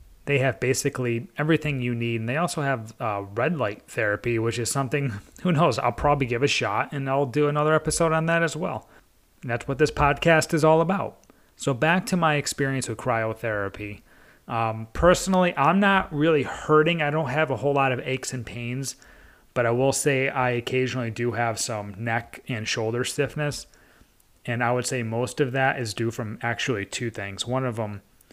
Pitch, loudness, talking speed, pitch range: 130 Hz, -24 LUFS, 195 wpm, 115-150 Hz